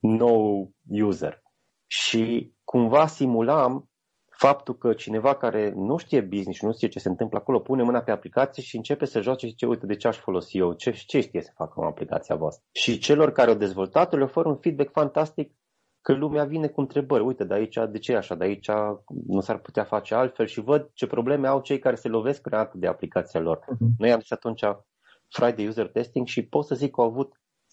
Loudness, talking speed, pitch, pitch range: -25 LUFS, 210 wpm, 120 Hz, 105-140 Hz